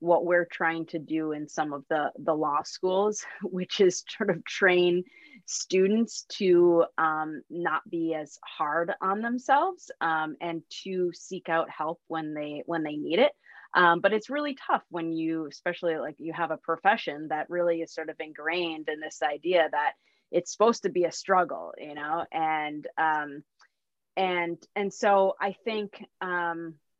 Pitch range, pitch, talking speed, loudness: 160-190 Hz, 170 Hz, 170 wpm, -28 LUFS